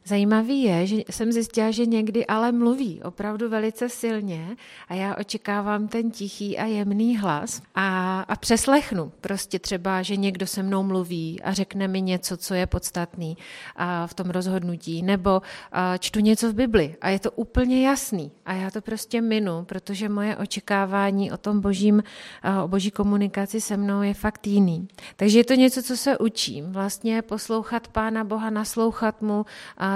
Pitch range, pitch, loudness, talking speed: 190-220 Hz, 205 Hz, -24 LUFS, 170 wpm